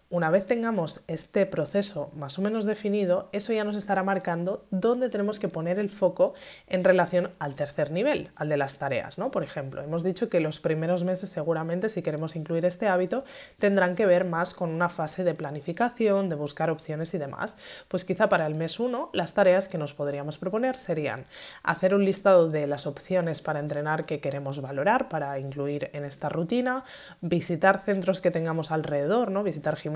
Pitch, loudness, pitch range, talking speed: 175 Hz, -27 LUFS, 155-195 Hz, 190 wpm